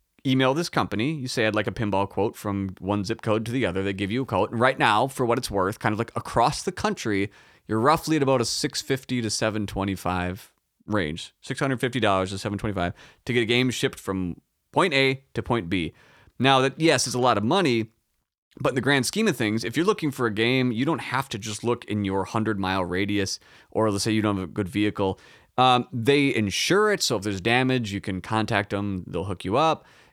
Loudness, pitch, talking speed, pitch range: -24 LUFS, 110 Hz, 230 wpm, 100-130 Hz